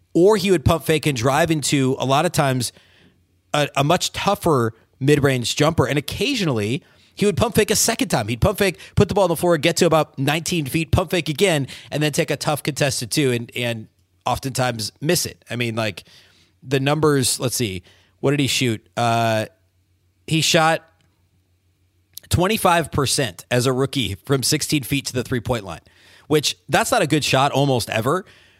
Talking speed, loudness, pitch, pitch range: 190 wpm, -20 LUFS, 135 Hz, 115-160 Hz